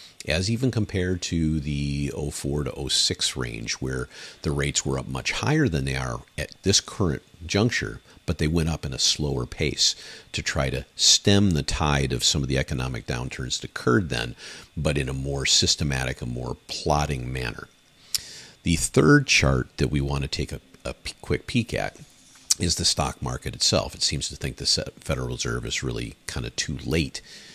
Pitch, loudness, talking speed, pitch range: 70 Hz, -24 LUFS, 185 wpm, 65-85 Hz